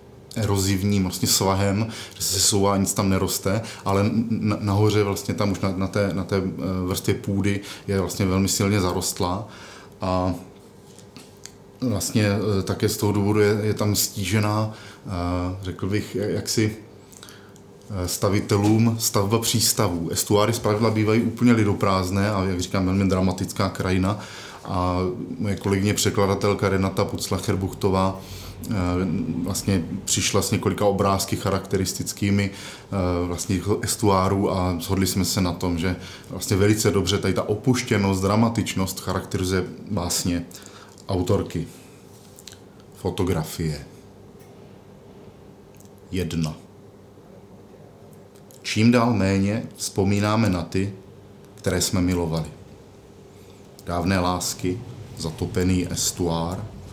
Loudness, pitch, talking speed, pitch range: -23 LUFS, 100 Hz, 105 wpm, 95-105 Hz